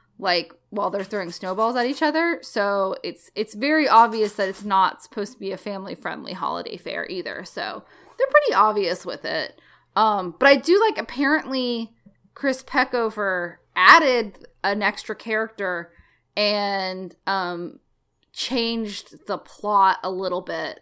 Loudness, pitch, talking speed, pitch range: -22 LUFS, 210 Hz, 145 wpm, 195-250 Hz